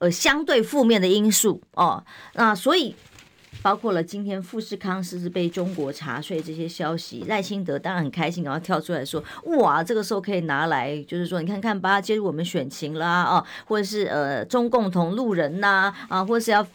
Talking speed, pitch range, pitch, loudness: 315 characters per minute, 170-210 Hz, 185 Hz, -23 LUFS